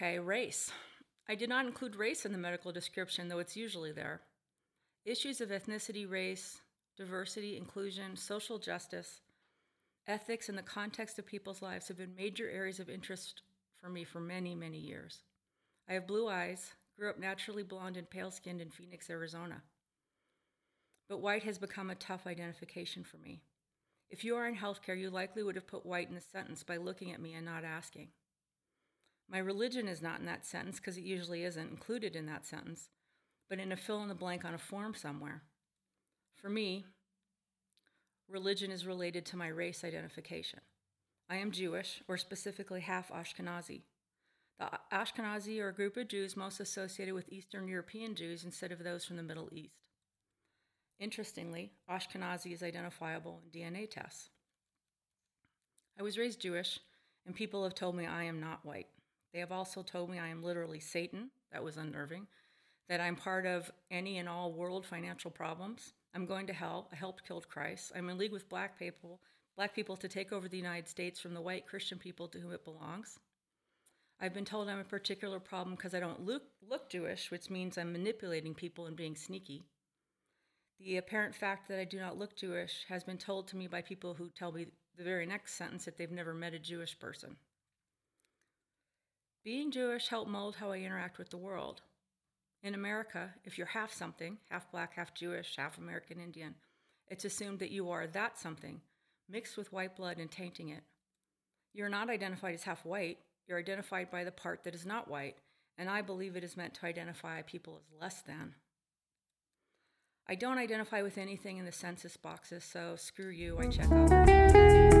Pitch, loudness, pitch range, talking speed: 185 Hz, -38 LUFS, 170-200 Hz, 185 wpm